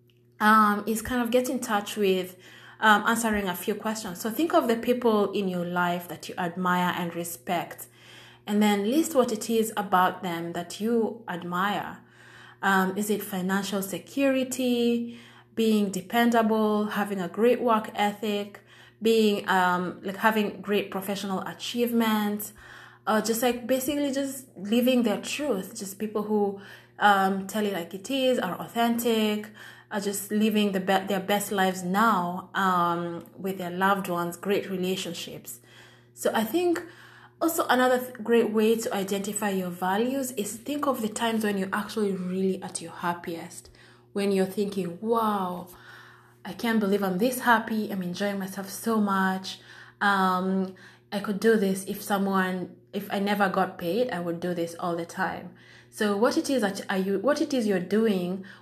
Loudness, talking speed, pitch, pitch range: -26 LUFS, 165 wpm, 205 Hz, 185-225 Hz